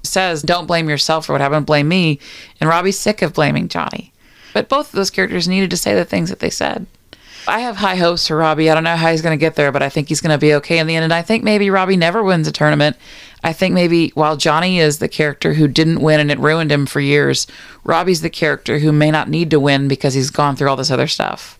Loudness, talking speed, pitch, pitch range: -15 LUFS, 270 wpm, 160 Hz, 150-175 Hz